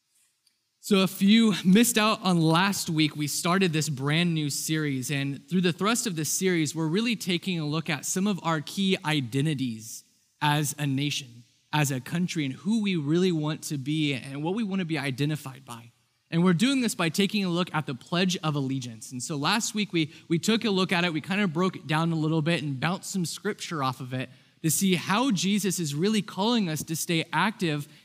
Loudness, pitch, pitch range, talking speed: -26 LUFS, 165 Hz, 145-190 Hz, 220 wpm